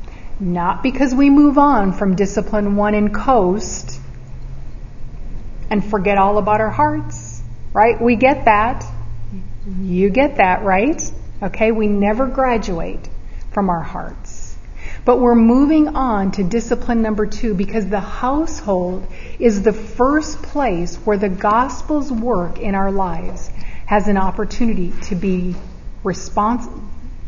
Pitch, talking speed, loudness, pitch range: 205 Hz, 130 wpm, -17 LUFS, 175-235 Hz